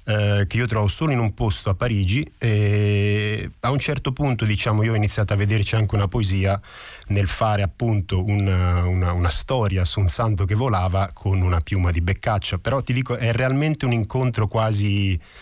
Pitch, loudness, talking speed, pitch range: 105 Hz, -21 LUFS, 185 wpm, 95-115 Hz